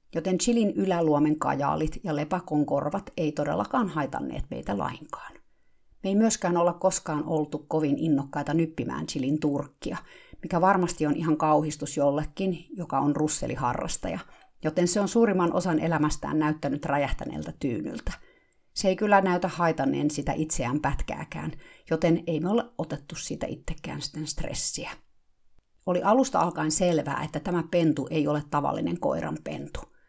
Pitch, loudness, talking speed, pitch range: 155 Hz, -27 LUFS, 140 wpm, 150-180 Hz